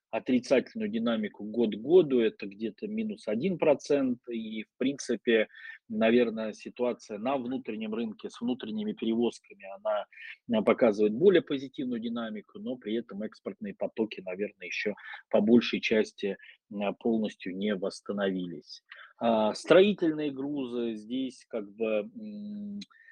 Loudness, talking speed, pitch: -30 LUFS, 115 wpm, 120 Hz